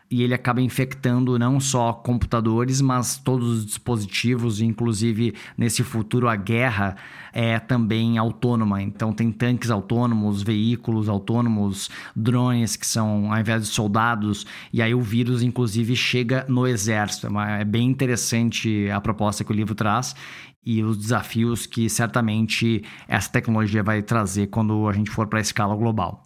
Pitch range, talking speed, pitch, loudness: 110-120 Hz, 150 wpm, 115 Hz, -22 LUFS